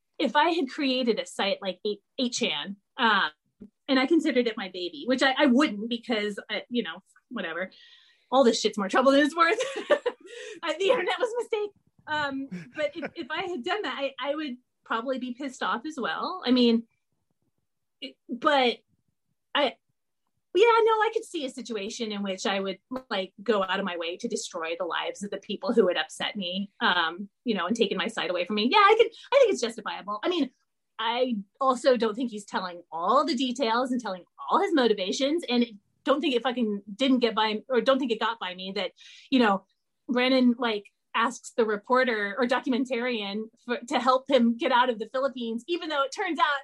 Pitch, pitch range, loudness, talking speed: 250 Hz, 215-285 Hz, -26 LUFS, 205 wpm